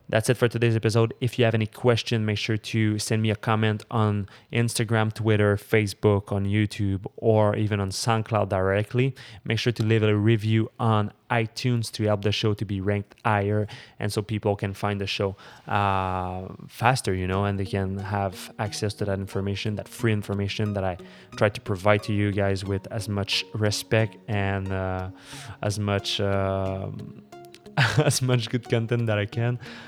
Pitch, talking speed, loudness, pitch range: 105 Hz, 180 wpm, -25 LUFS, 100-115 Hz